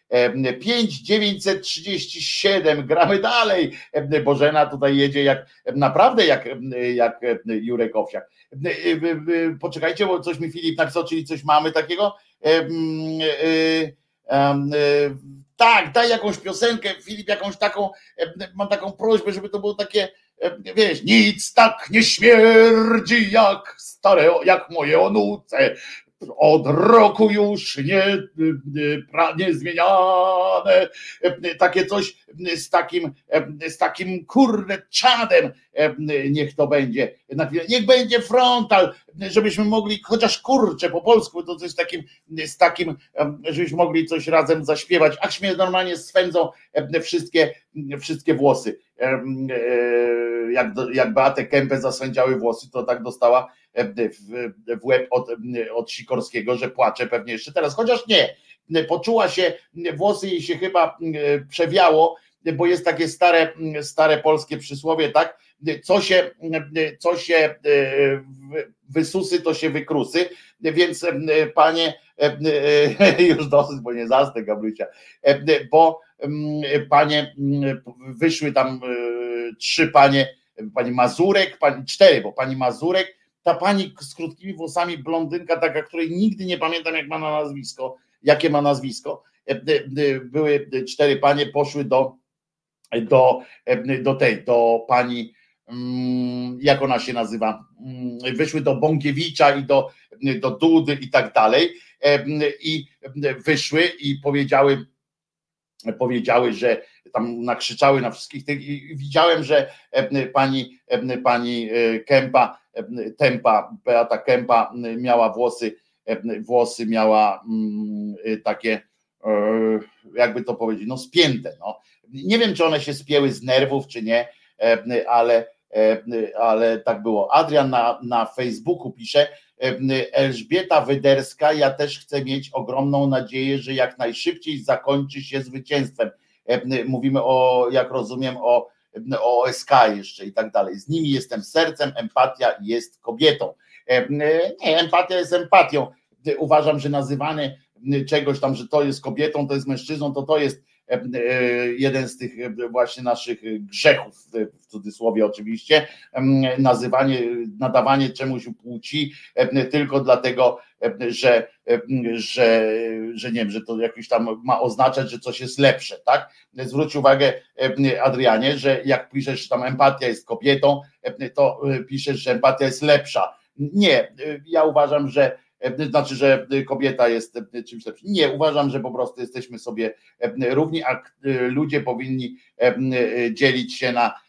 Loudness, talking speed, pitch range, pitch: -20 LUFS, 125 wpm, 130-165 Hz, 145 Hz